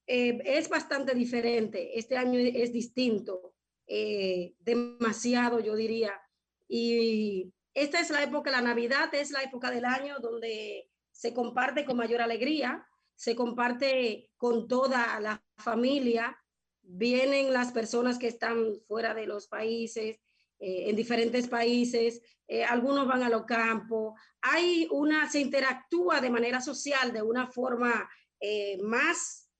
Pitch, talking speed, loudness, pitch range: 240 Hz, 135 wpm, -30 LUFS, 225-260 Hz